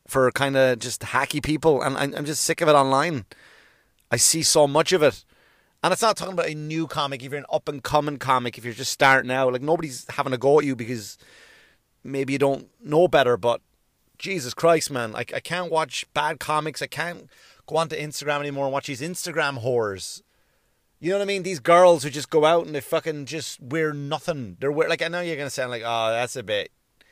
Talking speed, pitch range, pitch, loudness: 230 wpm, 130-160 Hz, 150 Hz, -23 LUFS